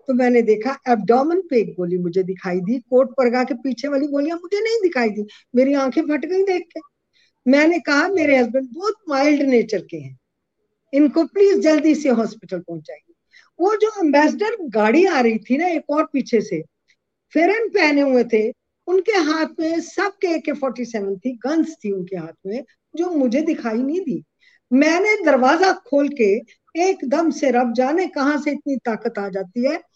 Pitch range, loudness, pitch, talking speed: 235-330 Hz, -19 LUFS, 280 Hz, 180 wpm